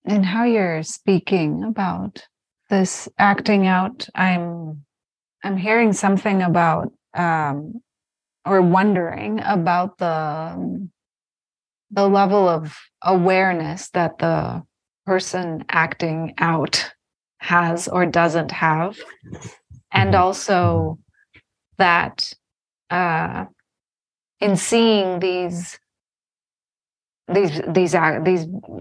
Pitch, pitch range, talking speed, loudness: 185 Hz, 165-200 Hz, 85 wpm, -19 LUFS